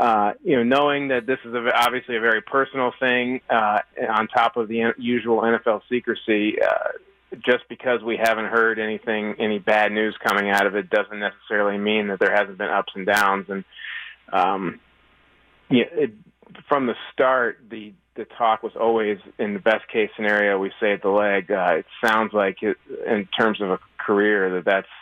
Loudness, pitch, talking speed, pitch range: -21 LUFS, 115 Hz, 190 wpm, 105-125 Hz